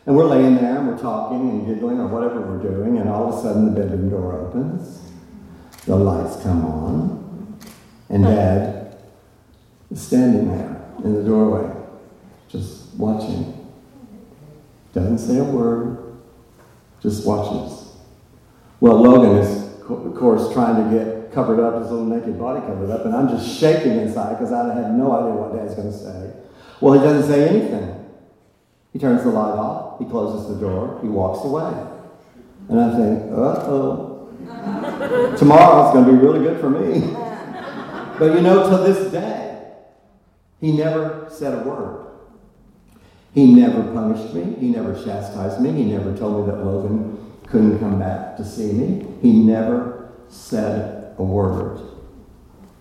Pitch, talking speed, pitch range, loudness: 115 Hz, 160 wpm, 105-160 Hz, -18 LUFS